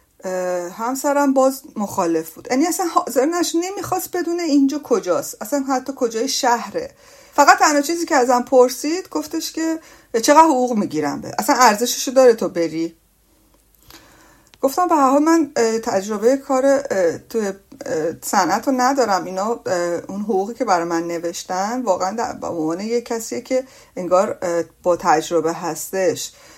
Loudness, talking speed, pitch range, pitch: -19 LUFS, 135 wpm, 185-285 Hz, 250 Hz